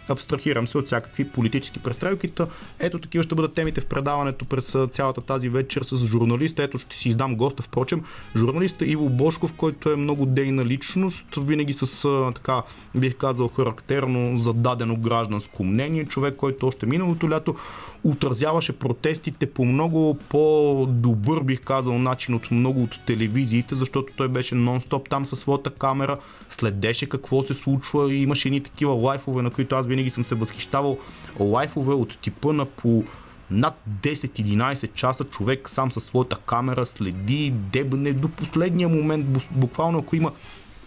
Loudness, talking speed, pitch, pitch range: -24 LUFS, 155 wpm, 135 Hz, 120-145 Hz